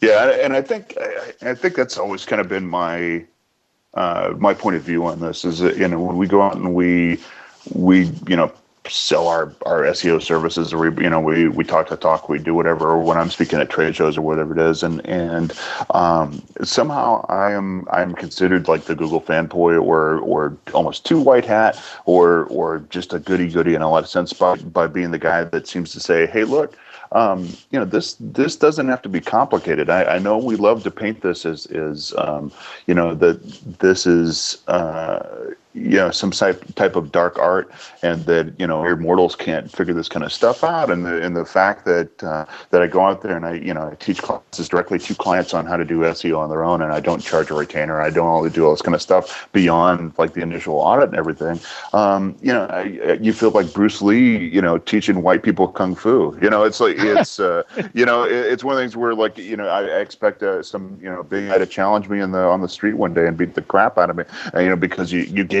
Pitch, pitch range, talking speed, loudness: 90 Hz, 85-95 Hz, 240 wpm, -18 LUFS